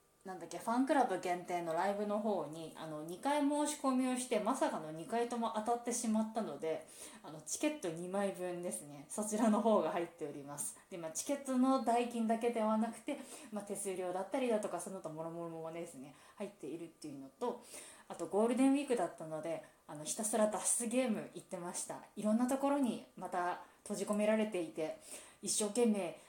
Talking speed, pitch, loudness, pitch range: 410 characters per minute, 205 Hz, -37 LUFS, 170-240 Hz